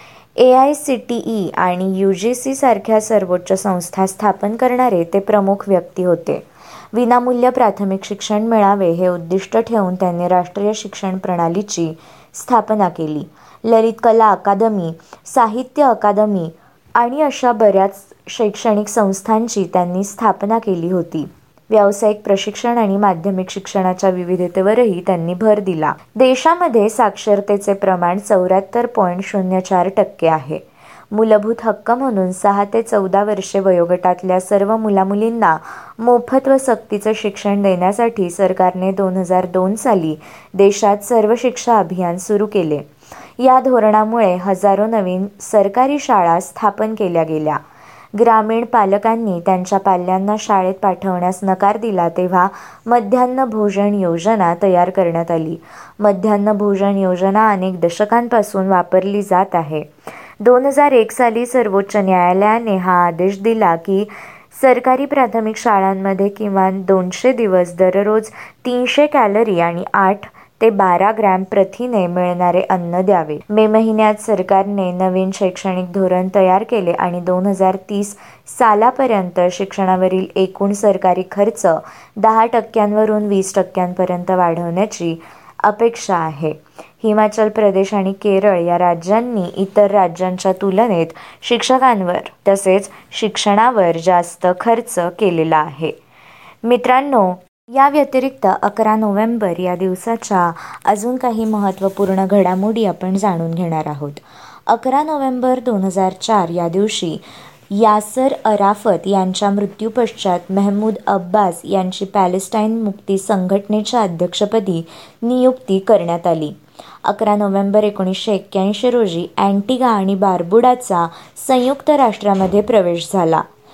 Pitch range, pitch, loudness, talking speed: 185-220 Hz, 200 Hz, -15 LUFS, 115 wpm